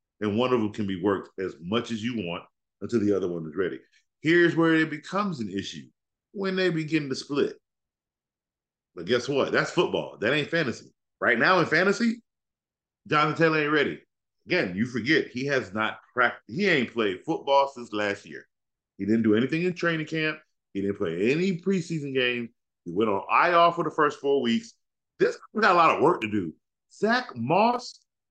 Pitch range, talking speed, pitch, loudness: 105-170 Hz, 195 wpm, 135 Hz, -25 LUFS